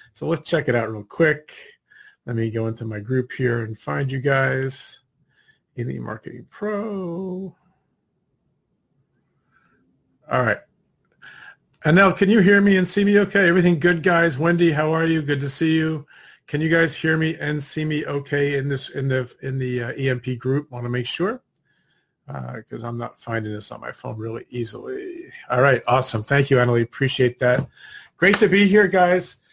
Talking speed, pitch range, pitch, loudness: 185 wpm, 125-175 Hz, 145 Hz, -21 LUFS